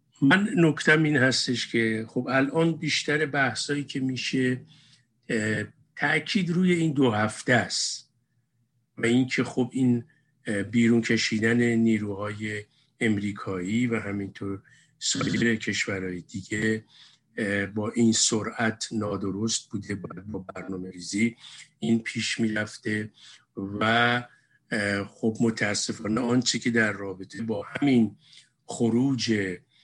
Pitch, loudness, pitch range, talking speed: 115 Hz, -26 LUFS, 105-130 Hz, 105 wpm